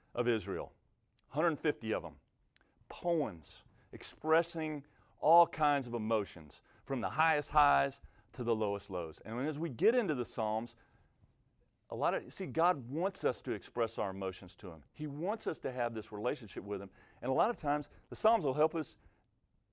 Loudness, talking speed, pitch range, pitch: -34 LUFS, 180 wpm, 105-155 Hz, 120 Hz